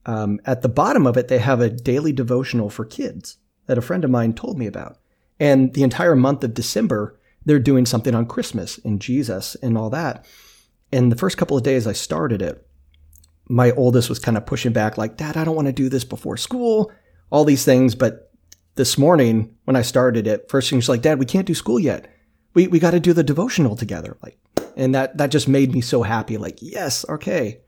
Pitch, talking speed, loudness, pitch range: 125 Hz, 225 wpm, -19 LUFS, 110-140 Hz